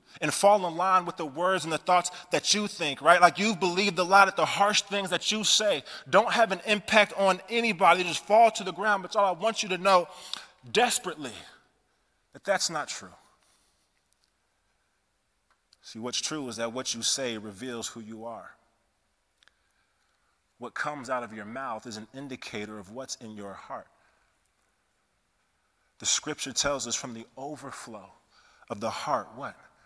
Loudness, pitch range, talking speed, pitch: -26 LUFS, 115-195 Hz, 175 wpm, 170 Hz